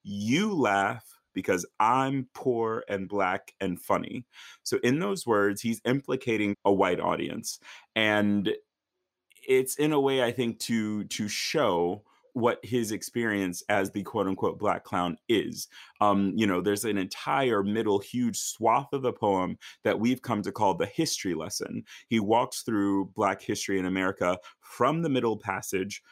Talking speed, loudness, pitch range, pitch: 160 wpm, -28 LUFS, 100-130 Hz, 110 Hz